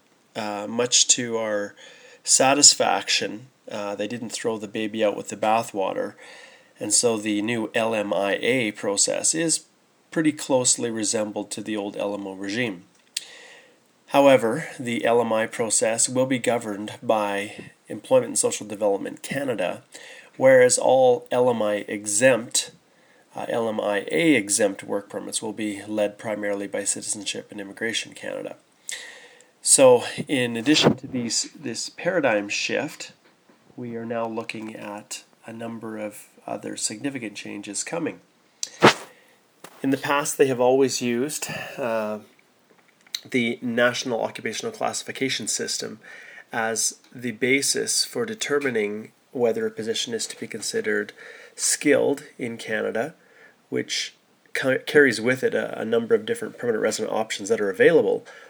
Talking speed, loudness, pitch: 125 wpm, -23 LUFS, 125 Hz